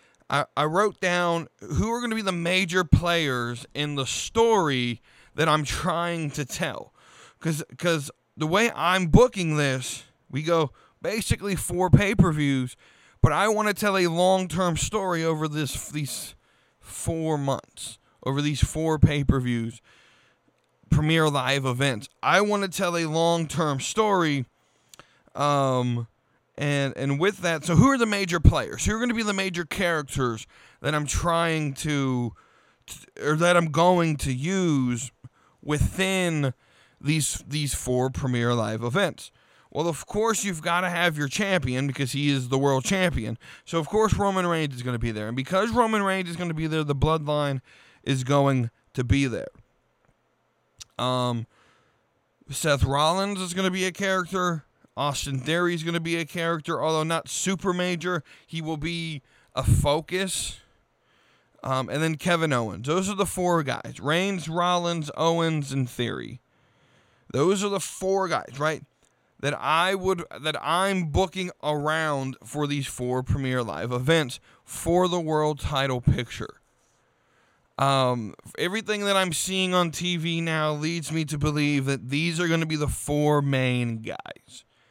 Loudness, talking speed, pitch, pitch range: -25 LUFS, 160 wpm, 155 Hz, 130-175 Hz